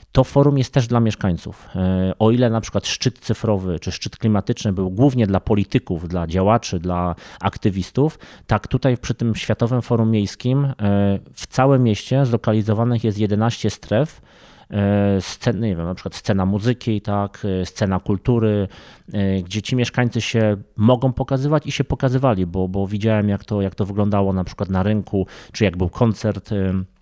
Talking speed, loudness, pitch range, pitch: 160 wpm, -20 LUFS, 95-120 Hz, 105 Hz